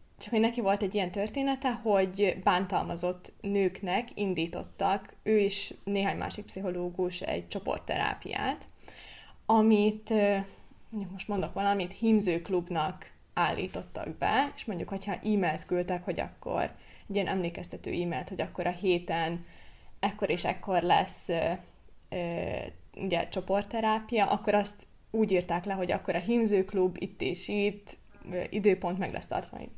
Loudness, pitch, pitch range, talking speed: -31 LUFS, 195 Hz, 180-205 Hz, 135 wpm